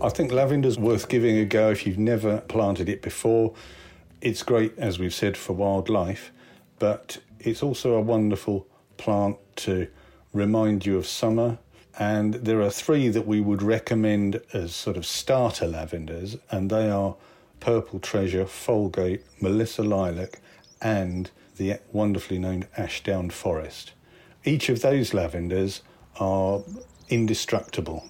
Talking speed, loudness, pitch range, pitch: 135 wpm, -25 LUFS, 95-115 Hz, 105 Hz